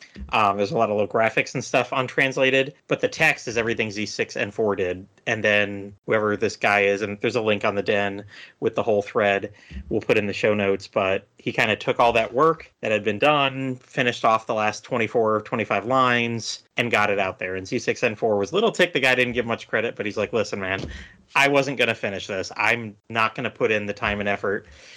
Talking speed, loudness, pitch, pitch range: 230 wpm, -22 LUFS, 110 Hz, 100-125 Hz